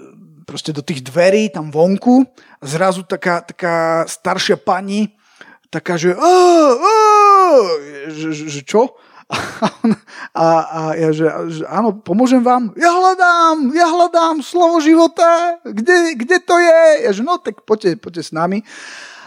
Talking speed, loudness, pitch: 140 wpm, -13 LUFS, 220 Hz